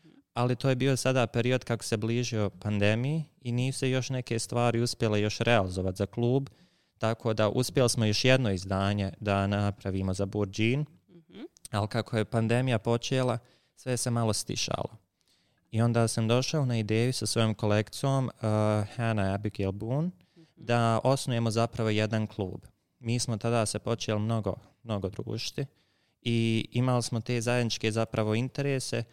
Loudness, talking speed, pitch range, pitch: -29 LUFS, 150 wpm, 105-125 Hz, 115 Hz